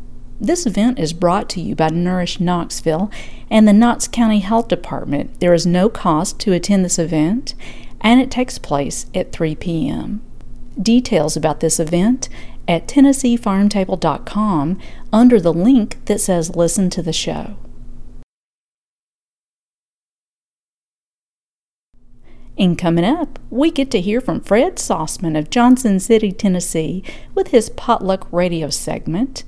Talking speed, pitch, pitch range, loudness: 130 wpm, 190 Hz, 165-230 Hz, -16 LUFS